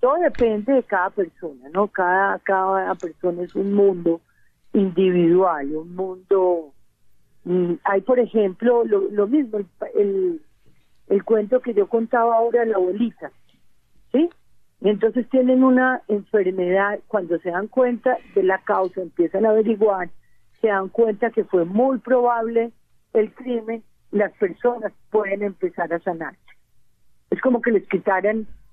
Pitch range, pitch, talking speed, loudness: 185-235 Hz, 205 Hz, 140 wpm, -21 LUFS